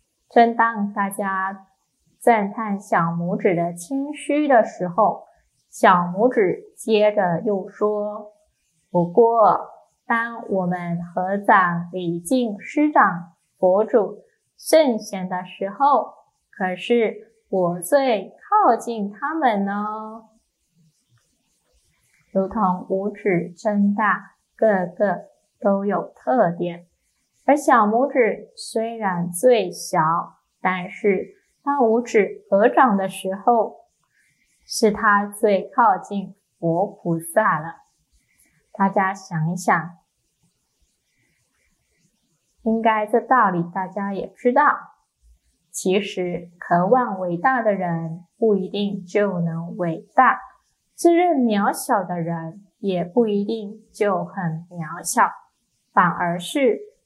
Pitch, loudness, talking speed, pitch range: 200 Hz, -21 LUFS, 145 characters per minute, 180-230 Hz